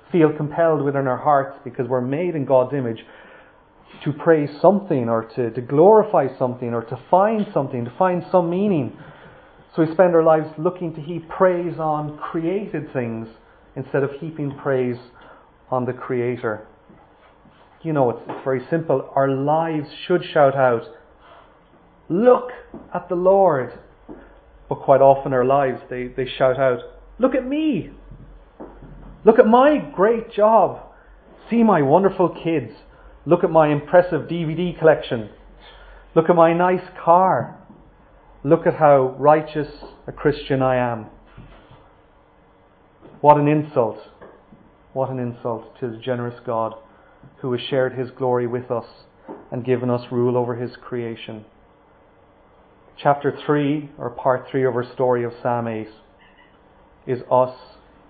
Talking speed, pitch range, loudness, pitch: 145 wpm, 125-165 Hz, -20 LUFS, 140 Hz